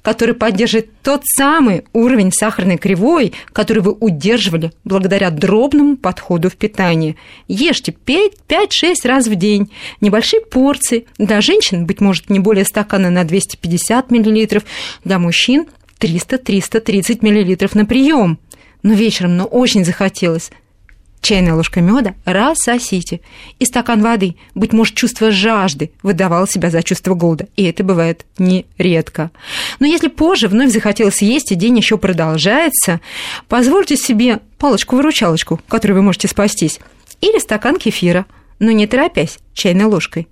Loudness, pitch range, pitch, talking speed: -13 LUFS, 185-235 Hz, 210 Hz, 130 wpm